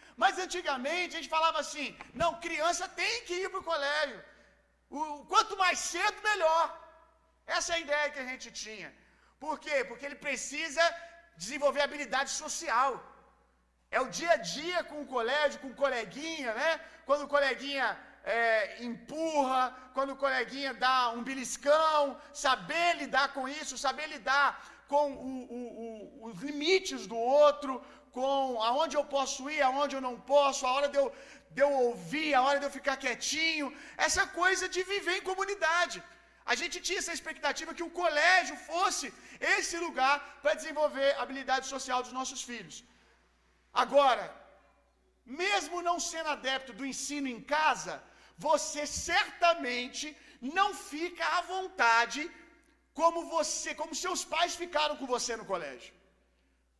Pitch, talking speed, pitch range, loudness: 290 Hz, 150 wpm, 265-330 Hz, -31 LUFS